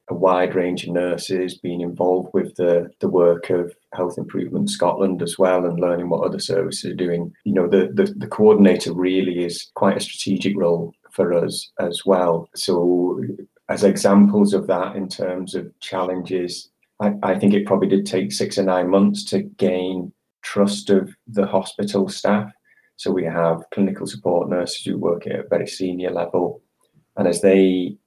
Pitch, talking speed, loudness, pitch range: 90 Hz, 175 wpm, -20 LUFS, 90-95 Hz